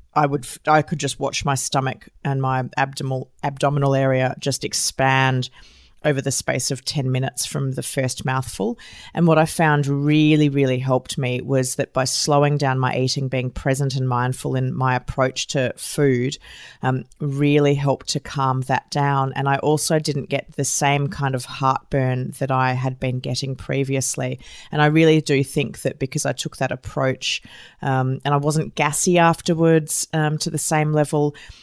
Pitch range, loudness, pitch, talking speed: 130-150 Hz, -21 LUFS, 135 Hz, 180 wpm